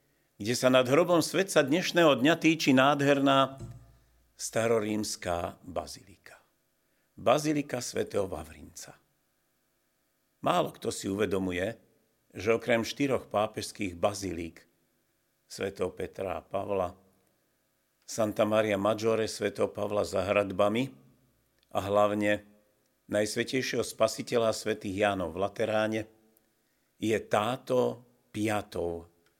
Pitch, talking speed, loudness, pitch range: 110 Hz, 90 wpm, -29 LUFS, 100-125 Hz